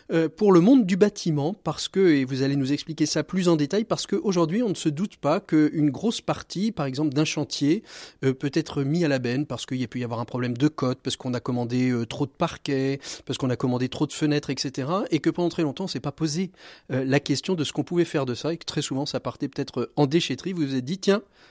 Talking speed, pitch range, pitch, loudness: 265 wpm, 135-170 Hz, 150 Hz, -25 LUFS